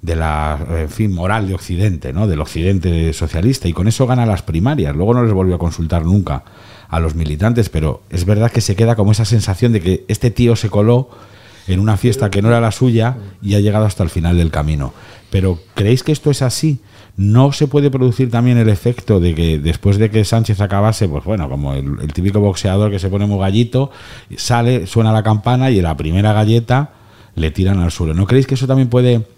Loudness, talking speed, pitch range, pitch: -15 LUFS, 225 wpm, 90-120 Hz, 105 Hz